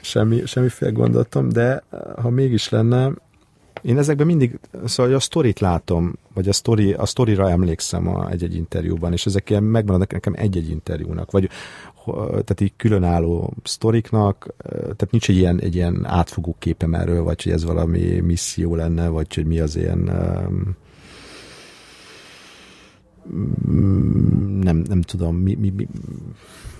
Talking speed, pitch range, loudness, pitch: 140 wpm, 85-115 Hz, -20 LUFS, 95 Hz